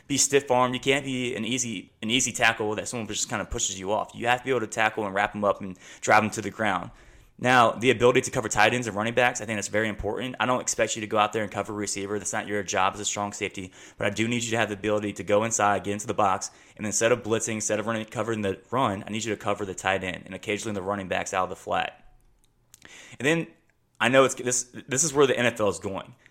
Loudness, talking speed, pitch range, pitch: -25 LUFS, 290 wpm, 105-120 Hz, 110 Hz